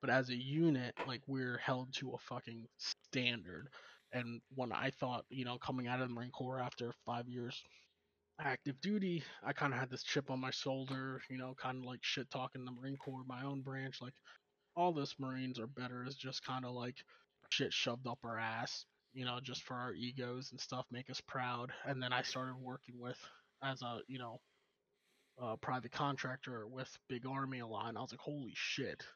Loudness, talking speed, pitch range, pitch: -43 LUFS, 210 wpm, 125-130 Hz, 130 Hz